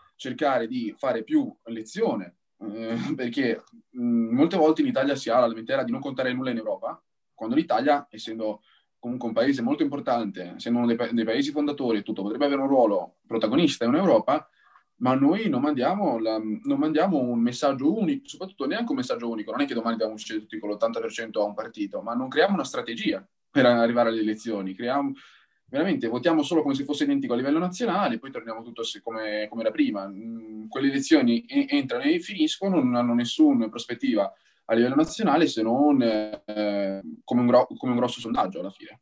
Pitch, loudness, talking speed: 140 Hz, -25 LUFS, 190 wpm